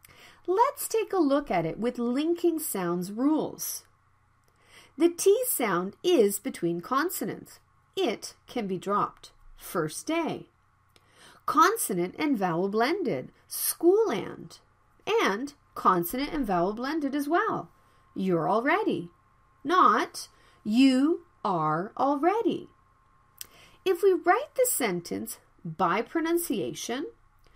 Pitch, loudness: 285 Hz, -27 LUFS